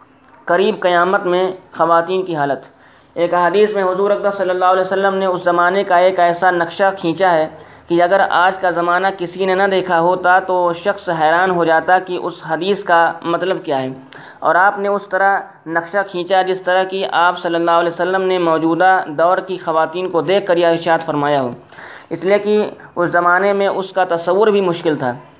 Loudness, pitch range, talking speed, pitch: -15 LUFS, 170-190 Hz, 200 wpm, 180 Hz